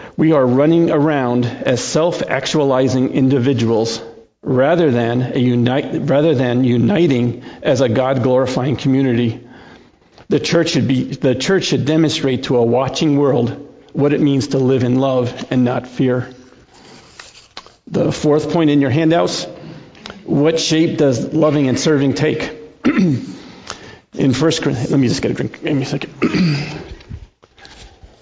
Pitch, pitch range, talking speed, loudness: 135 Hz, 125-150 Hz, 140 wpm, -16 LUFS